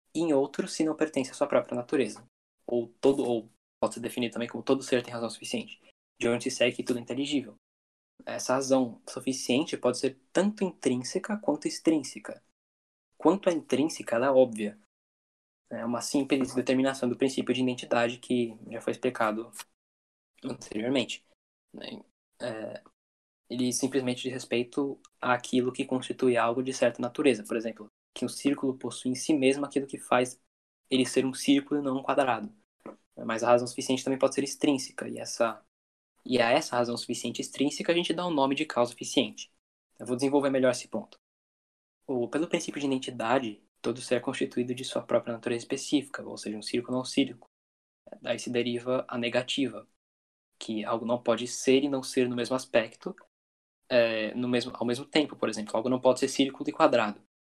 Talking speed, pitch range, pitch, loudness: 180 wpm, 120-135 Hz, 125 Hz, -29 LUFS